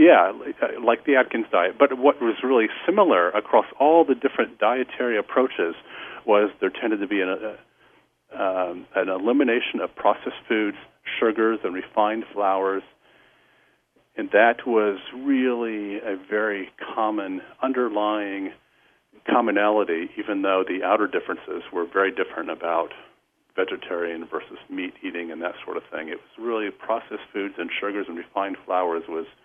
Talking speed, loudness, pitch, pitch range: 145 wpm, -23 LUFS, 110 Hz, 100-130 Hz